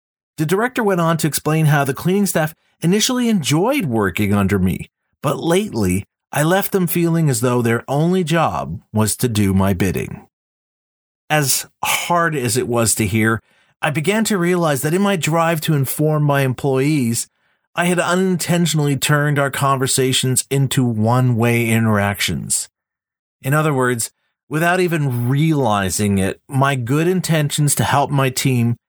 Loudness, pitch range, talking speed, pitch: -17 LUFS, 120-165 Hz, 155 wpm, 140 Hz